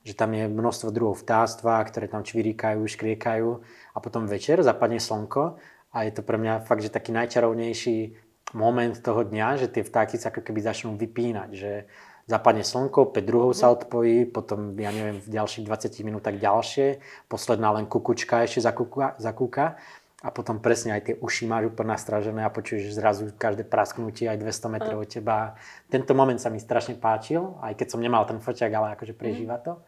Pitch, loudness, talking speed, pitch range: 115 Hz, -26 LUFS, 185 wpm, 110-120 Hz